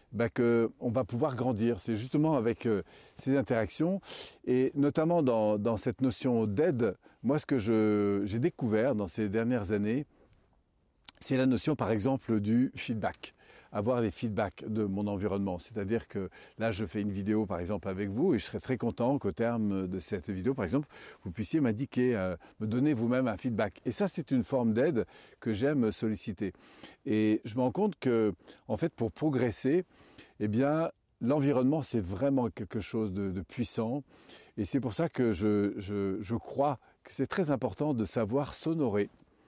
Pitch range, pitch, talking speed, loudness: 105-130 Hz, 115 Hz, 180 wpm, -31 LUFS